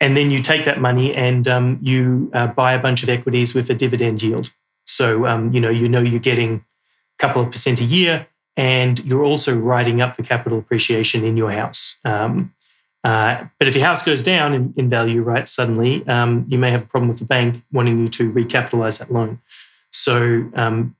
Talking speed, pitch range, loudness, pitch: 210 wpm, 115-130 Hz, -17 LUFS, 125 Hz